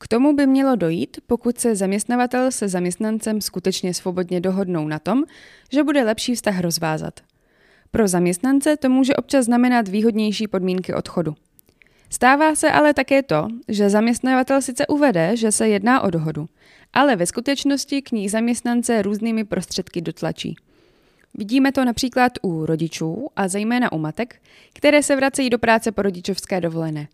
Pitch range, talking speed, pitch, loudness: 185-260 Hz, 155 wpm, 225 Hz, -20 LUFS